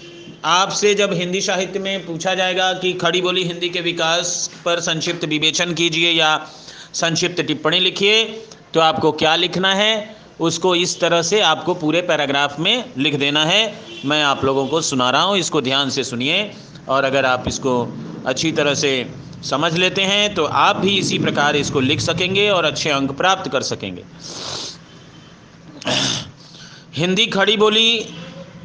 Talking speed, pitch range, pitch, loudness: 155 wpm, 150-185 Hz, 170 Hz, -17 LUFS